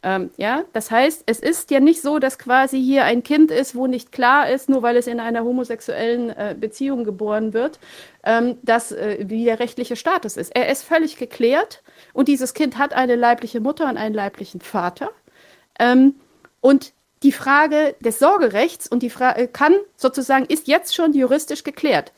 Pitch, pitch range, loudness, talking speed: 255 Hz, 235-280 Hz, -19 LUFS, 185 wpm